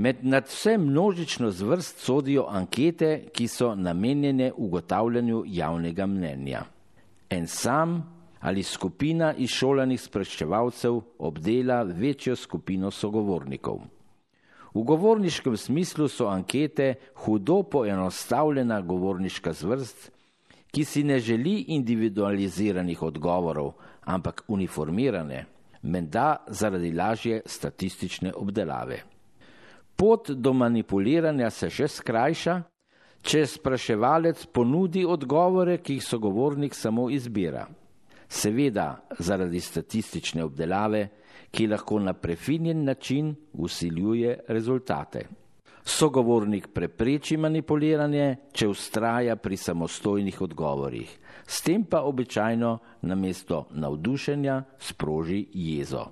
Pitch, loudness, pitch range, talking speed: 120 Hz, -27 LUFS, 95-145 Hz, 90 wpm